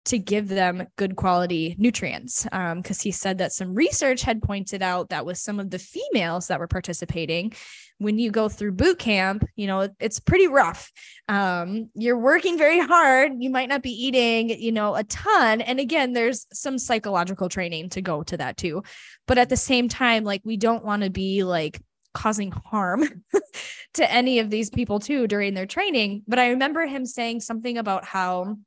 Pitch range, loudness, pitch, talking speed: 190-250 Hz, -23 LUFS, 215 Hz, 195 wpm